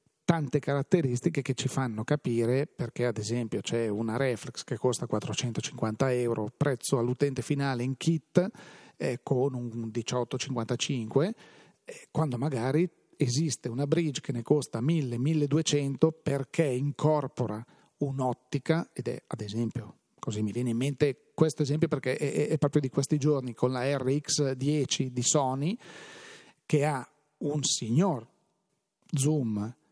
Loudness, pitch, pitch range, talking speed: -30 LUFS, 140 Hz, 125-155 Hz, 130 wpm